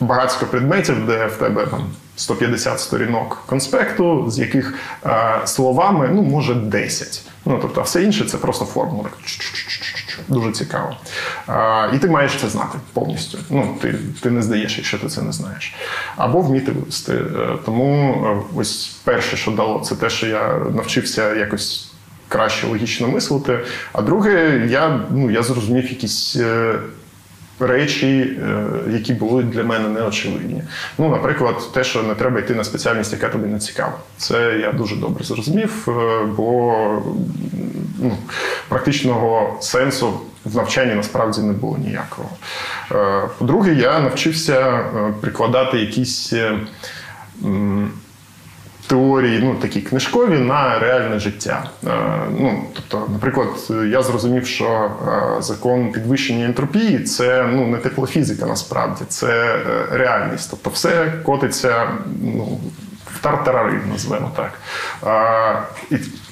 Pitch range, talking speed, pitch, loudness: 110-135 Hz, 130 wpm, 125 Hz, -18 LUFS